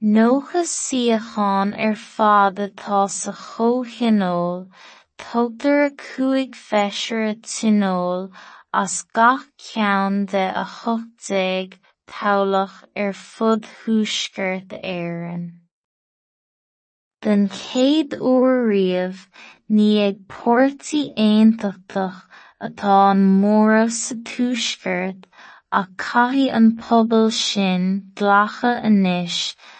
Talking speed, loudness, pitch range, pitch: 95 wpm, -19 LUFS, 195-235 Hz, 210 Hz